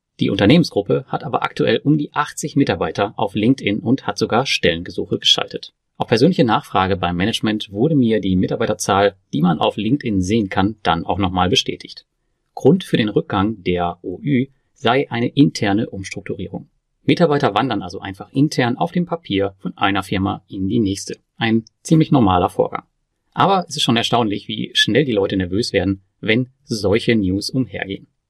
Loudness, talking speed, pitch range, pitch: -18 LUFS, 165 wpm, 100-135 Hz, 115 Hz